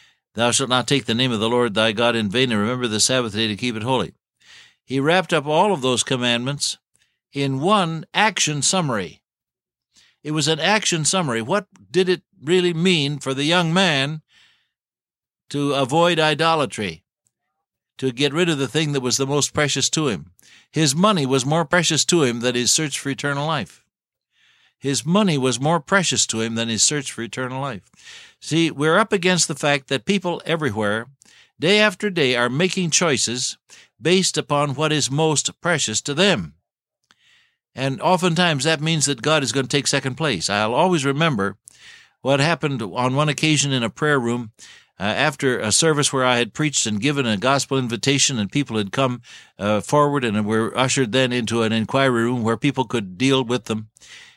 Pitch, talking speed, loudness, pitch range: 140 Hz, 185 wpm, -19 LUFS, 125-160 Hz